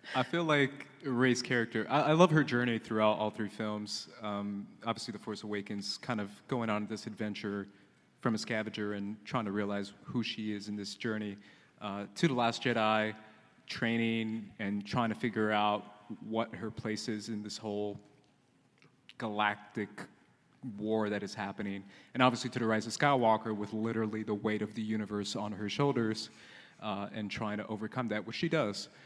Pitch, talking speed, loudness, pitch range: 110 Hz, 180 wpm, -34 LUFS, 105-115 Hz